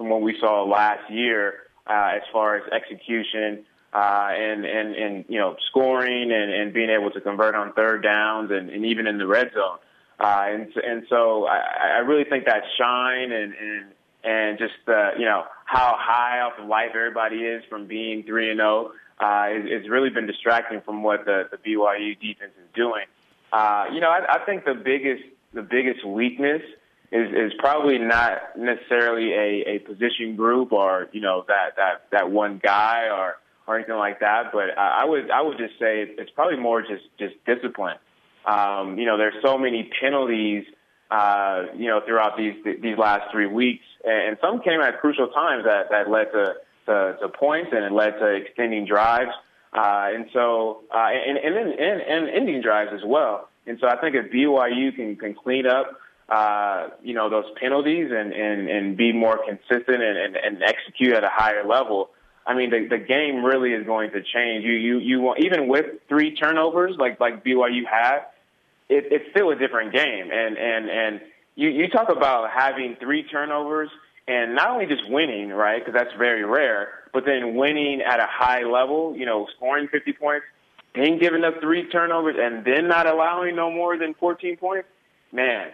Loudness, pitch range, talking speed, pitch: -22 LUFS, 105-130 Hz, 190 wpm, 115 Hz